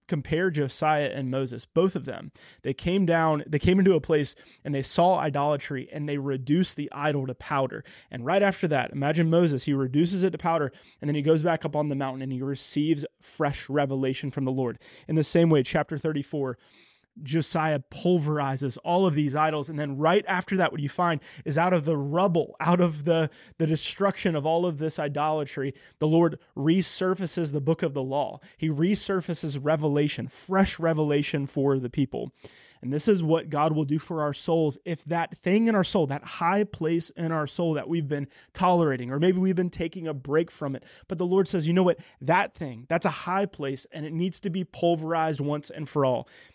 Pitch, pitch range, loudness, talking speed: 155 Hz, 145-170 Hz, -26 LUFS, 210 wpm